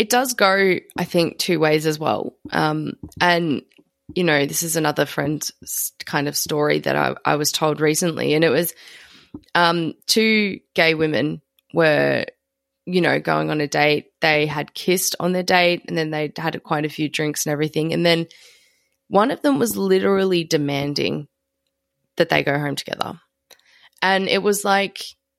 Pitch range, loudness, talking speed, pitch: 150-180 Hz, -20 LUFS, 175 wpm, 160 Hz